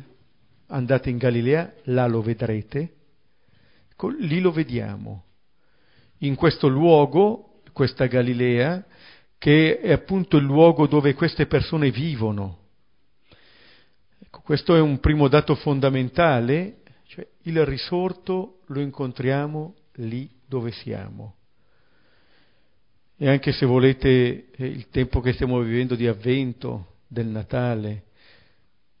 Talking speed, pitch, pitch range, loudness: 110 wpm, 135 Hz, 120-150 Hz, -22 LUFS